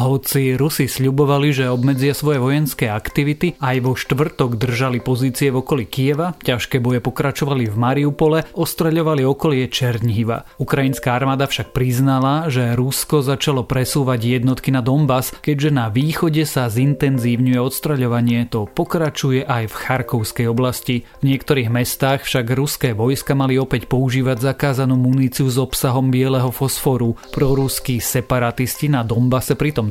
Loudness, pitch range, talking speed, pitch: -18 LUFS, 125-145 Hz, 135 wpm, 130 Hz